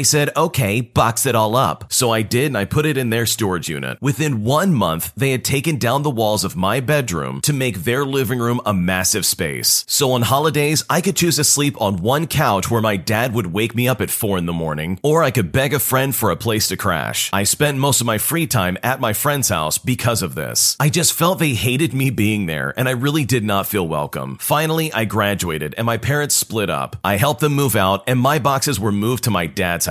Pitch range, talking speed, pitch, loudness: 105-145 Hz, 245 wpm, 125 Hz, -17 LUFS